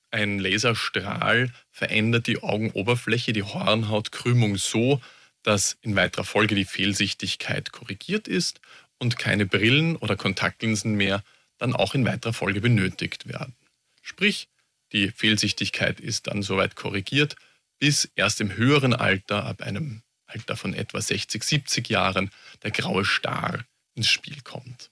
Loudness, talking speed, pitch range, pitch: -24 LUFS, 130 wpm, 100-125 Hz, 110 Hz